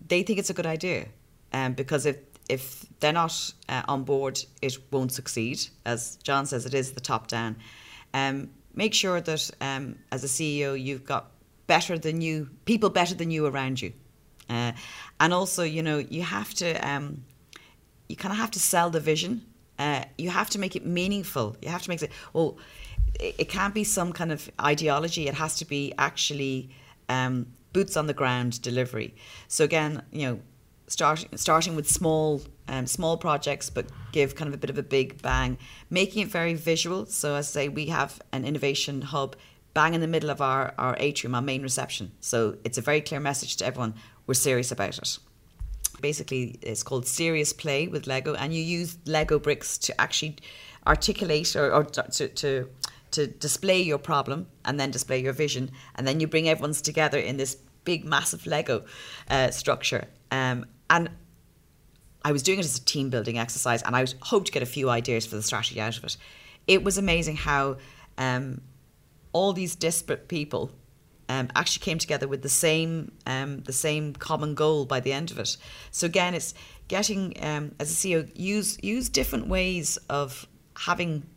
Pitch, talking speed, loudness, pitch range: 145 Hz, 190 wpm, -27 LUFS, 130-160 Hz